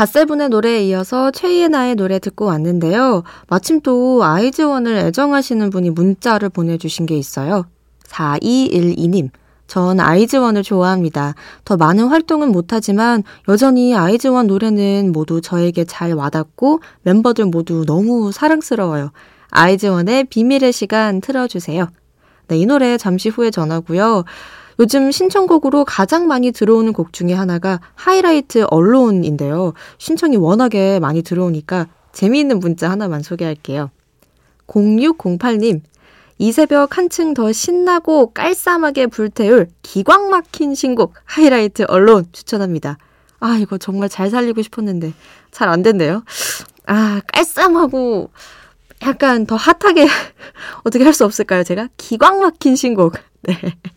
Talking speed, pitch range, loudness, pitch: 300 characters per minute, 180-260 Hz, -14 LUFS, 215 Hz